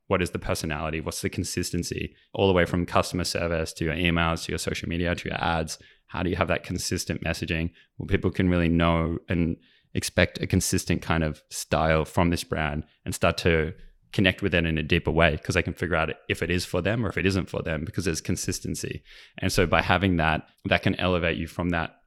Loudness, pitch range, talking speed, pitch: -26 LUFS, 80-95 Hz, 235 wpm, 85 Hz